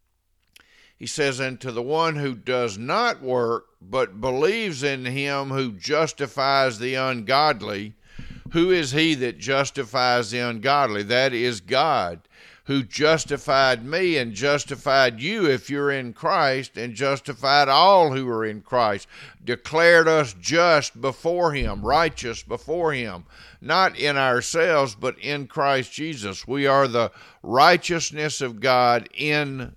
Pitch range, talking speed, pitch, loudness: 120-145 Hz, 135 wpm, 135 Hz, -22 LUFS